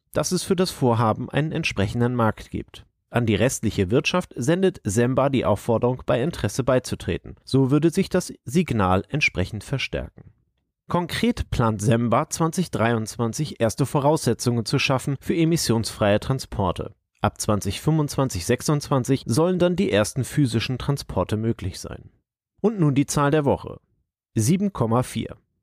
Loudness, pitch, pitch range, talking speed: -23 LUFS, 125 Hz, 110-150 Hz, 130 wpm